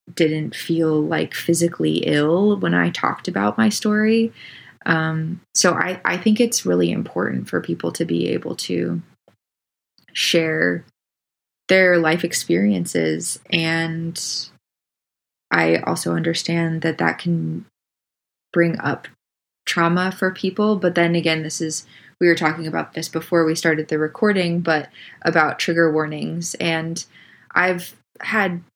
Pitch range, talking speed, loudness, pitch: 155-175 Hz, 130 wpm, -20 LUFS, 165 Hz